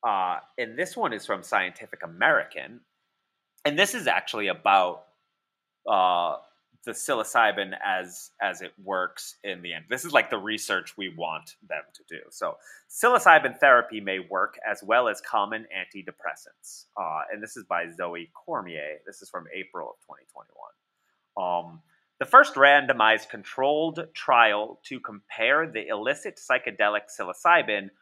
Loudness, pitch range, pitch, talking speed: -24 LUFS, 90-135 Hz, 105 Hz, 145 wpm